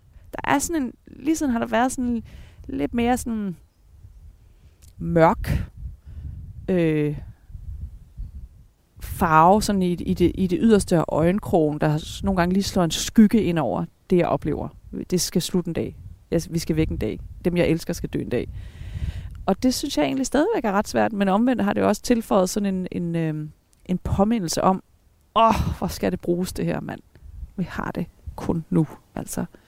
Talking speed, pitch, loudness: 185 wpm, 170 Hz, -23 LUFS